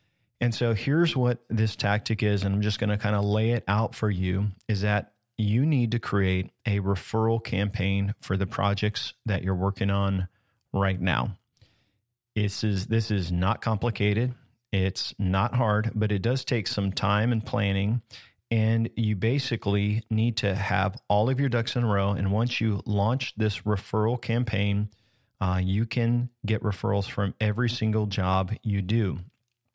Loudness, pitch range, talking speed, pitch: -27 LUFS, 100-115 Hz, 170 wpm, 105 Hz